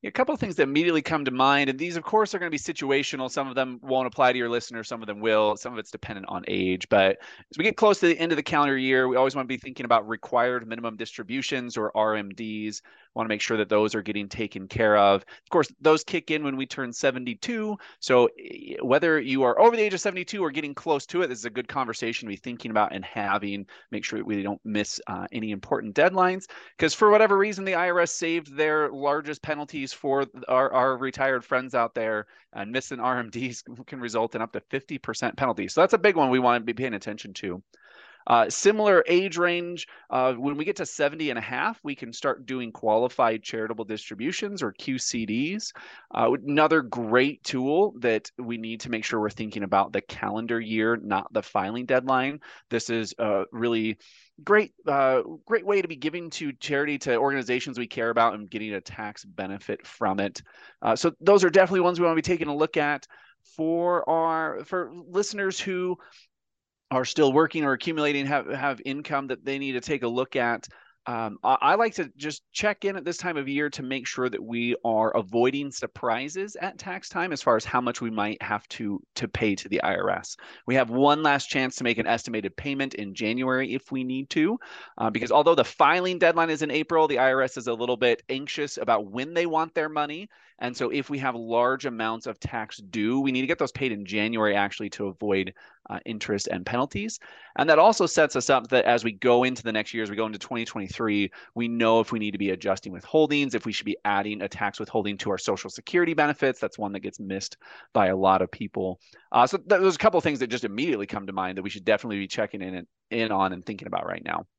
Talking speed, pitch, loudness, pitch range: 230 wpm, 130 Hz, -25 LUFS, 110-155 Hz